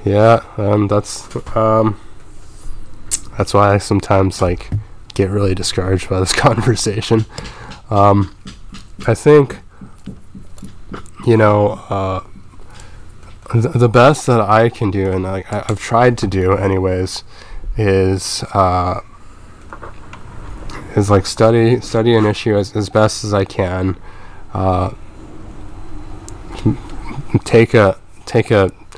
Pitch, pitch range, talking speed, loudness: 105 Hz, 95-110 Hz, 115 wpm, -15 LUFS